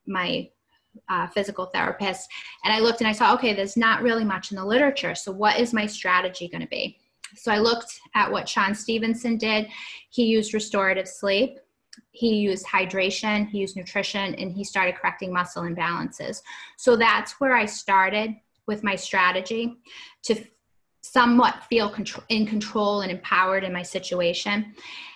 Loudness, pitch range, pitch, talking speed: -23 LUFS, 190-230 Hz, 210 Hz, 165 wpm